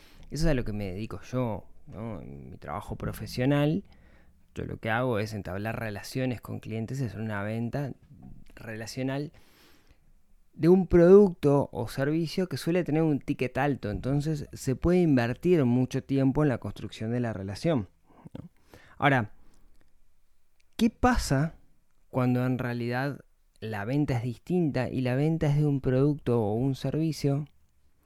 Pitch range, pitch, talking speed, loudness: 105-145 Hz, 125 Hz, 150 wpm, -28 LUFS